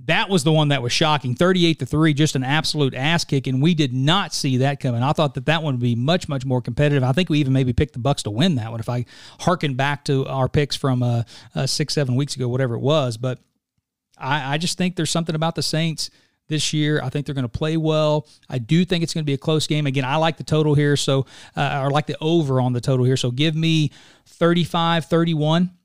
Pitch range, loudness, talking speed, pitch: 135-160 Hz, -20 LUFS, 260 wpm, 150 Hz